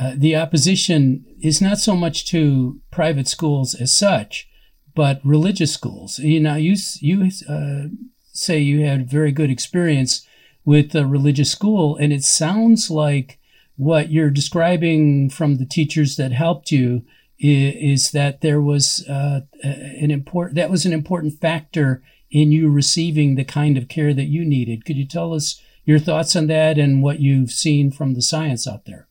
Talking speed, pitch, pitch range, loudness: 170 wpm, 150 Hz, 140-160 Hz, -18 LUFS